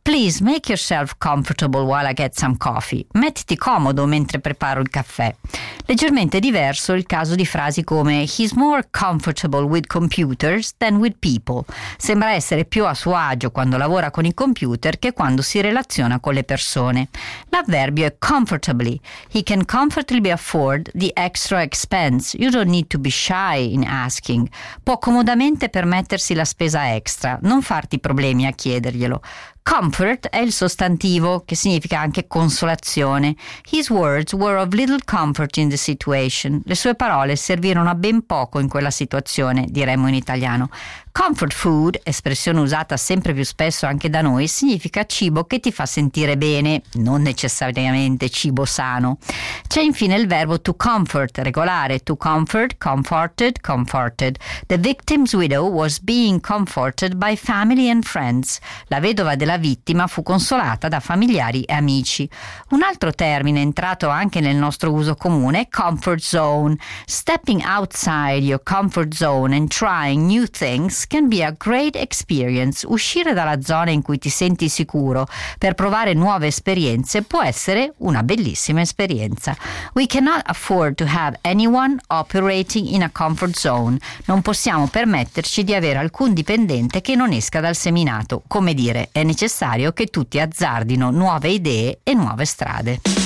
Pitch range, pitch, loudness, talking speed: 140-200 Hz, 160 Hz, -18 LUFS, 150 wpm